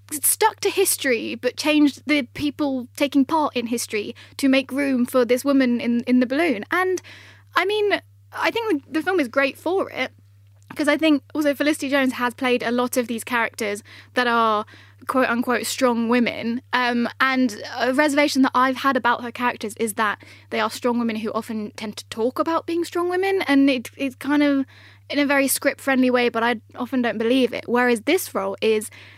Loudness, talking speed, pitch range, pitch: -21 LUFS, 200 wpm, 235-290 Hz, 255 Hz